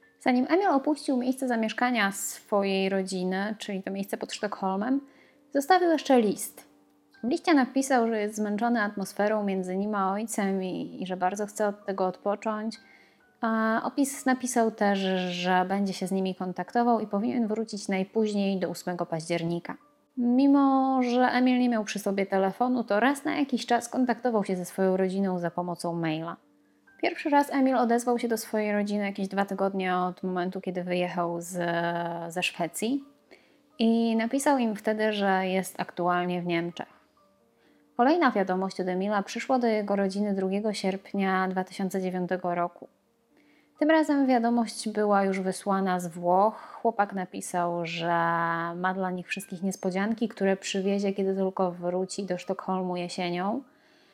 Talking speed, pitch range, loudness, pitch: 150 wpm, 185-235 Hz, -27 LUFS, 200 Hz